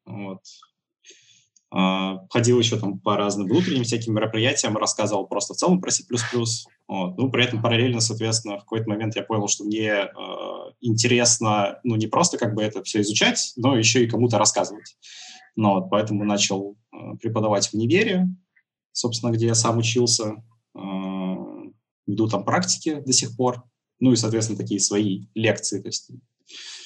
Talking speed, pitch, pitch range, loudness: 160 wpm, 110 Hz, 100-120 Hz, -22 LUFS